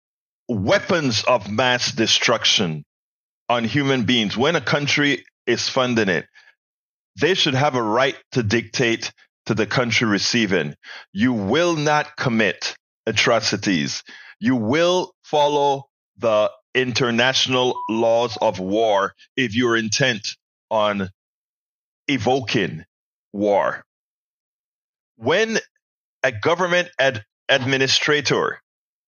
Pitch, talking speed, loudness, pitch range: 130 Hz, 100 wpm, -20 LUFS, 115-150 Hz